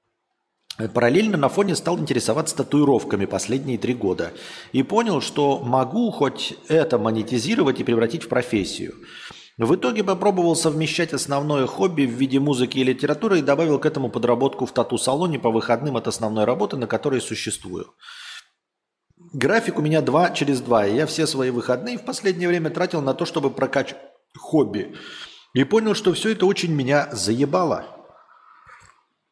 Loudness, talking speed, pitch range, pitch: -21 LUFS, 150 wpm, 125-170 Hz, 140 Hz